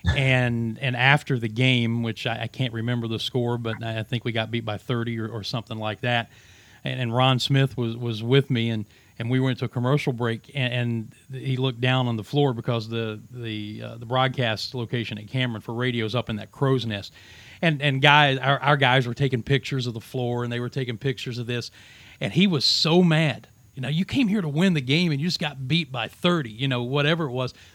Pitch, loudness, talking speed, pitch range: 125 Hz, -24 LUFS, 240 wpm, 115-135 Hz